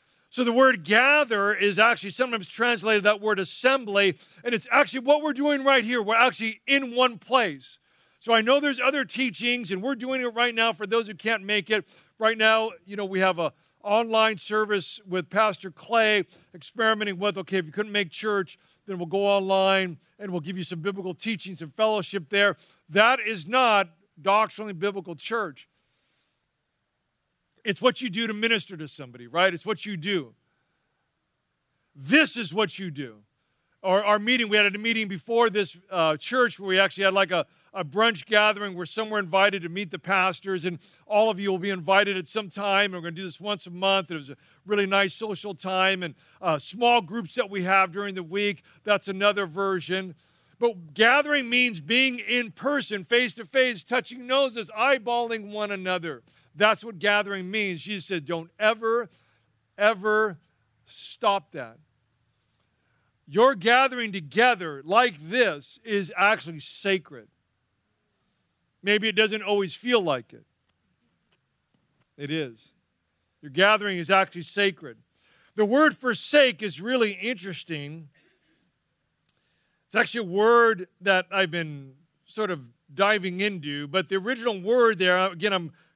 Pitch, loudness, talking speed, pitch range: 200 Hz, -24 LUFS, 165 wpm, 180-225 Hz